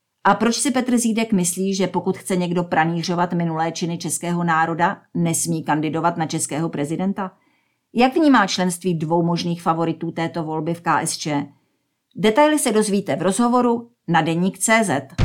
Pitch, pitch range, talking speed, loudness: 175 Hz, 165-200 Hz, 145 wpm, -20 LUFS